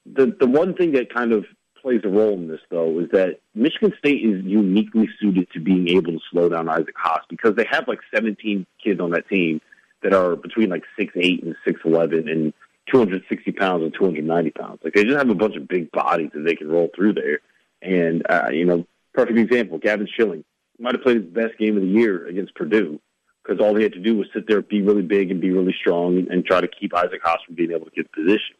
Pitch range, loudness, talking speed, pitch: 85-110 Hz, -20 LUFS, 250 wpm, 95 Hz